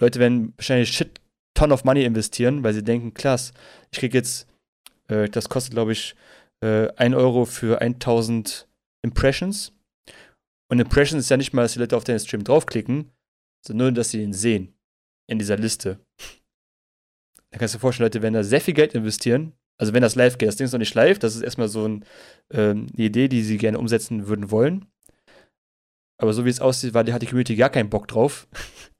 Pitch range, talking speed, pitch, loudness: 110-125 Hz, 205 wpm, 120 Hz, -21 LUFS